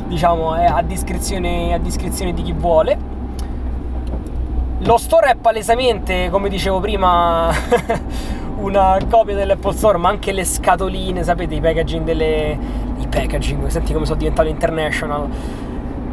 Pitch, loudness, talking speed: 165 Hz, -18 LUFS, 130 wpm